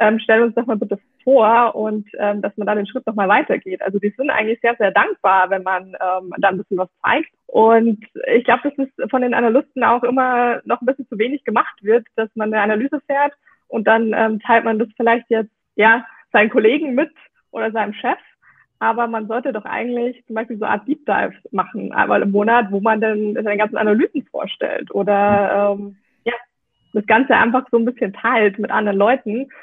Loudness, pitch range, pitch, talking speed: -18 LUFS, 210-245 Hz, 225 Hz, 215 wpm